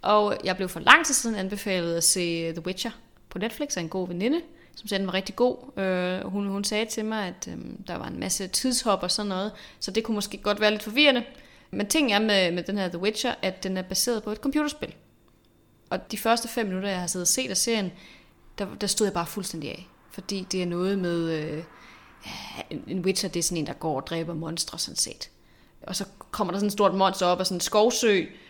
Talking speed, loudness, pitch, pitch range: 250 wpm, -26 LUFS, 195 Hz, 180-215 Hz